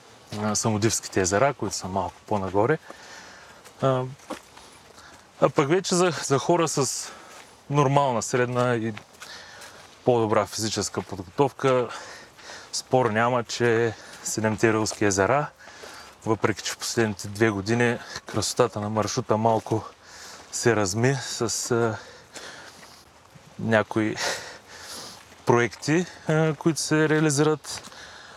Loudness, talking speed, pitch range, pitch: -24 LUFS, 100 wpm, 110-135 Hz, 115 Hz